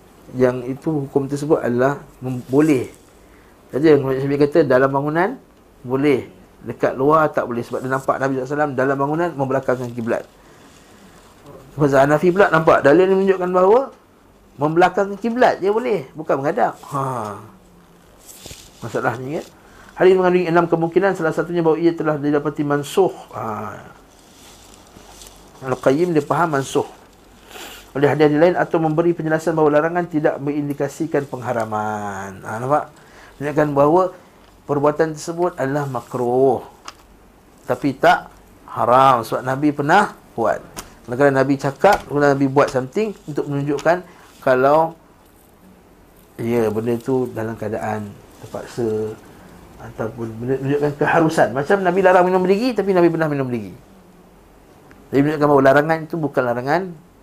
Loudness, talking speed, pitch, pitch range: -18 LUFS, 130 wpm, 145 Hz, 130-165 Hz